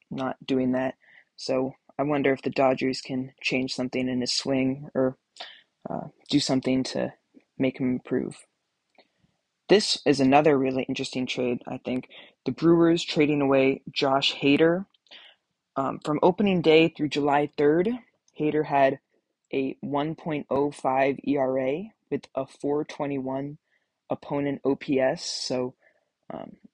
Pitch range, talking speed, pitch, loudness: 130-150 Hz, 125 wpm, 135 Hz, -25 LUFS